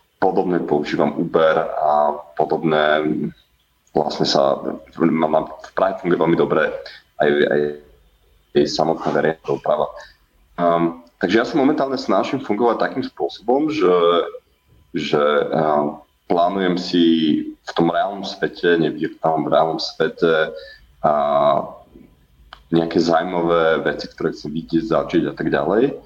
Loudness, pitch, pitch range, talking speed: -19 LUFS, 80 Hz, 75-90 Hz, 125 wpm